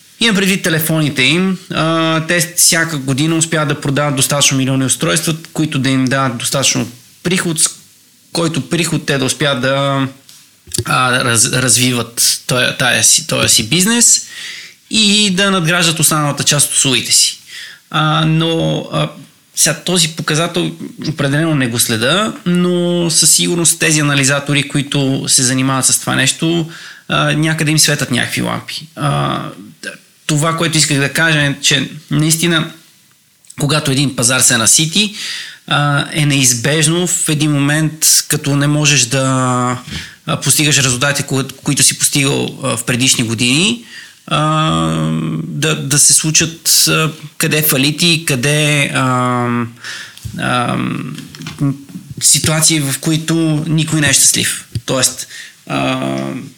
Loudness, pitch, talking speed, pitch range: -12 LUFS, 150 Hz, 110 wpm, 135-160 Hz